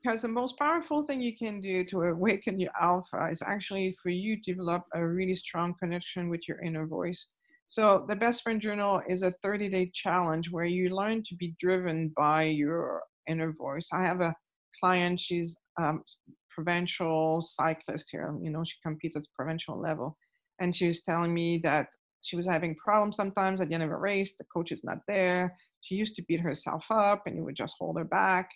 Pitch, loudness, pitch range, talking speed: 180 Hz, -31 LUFS, 165-195 Hz, 205 wpm